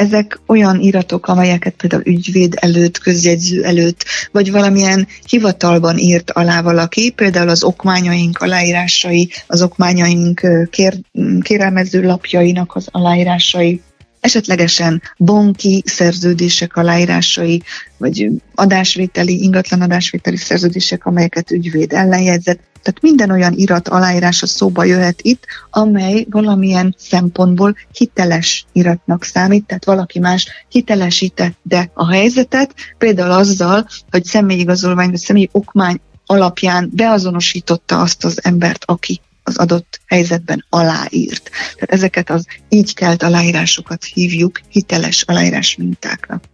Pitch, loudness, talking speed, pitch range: 180 Hz, -12 LUFS, 110 wpm, 175-195 Hz